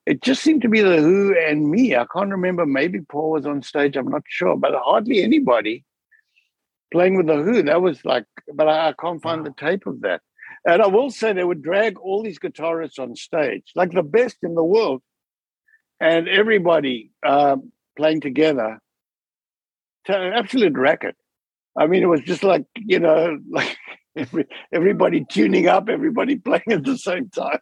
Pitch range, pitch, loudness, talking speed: 155-220 Hz, 175 Hz, -19 LUFS, 180 wpm